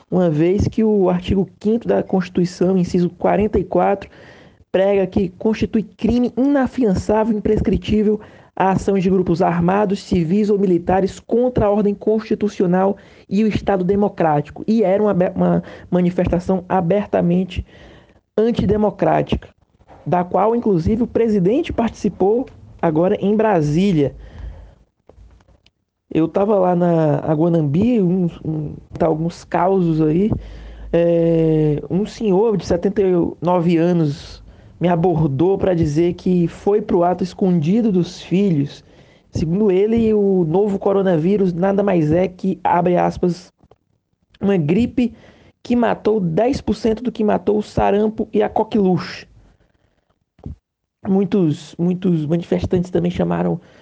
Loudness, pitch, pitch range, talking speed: -18 LUFS, 190 Hz, 170-210 Hz, 115 wpm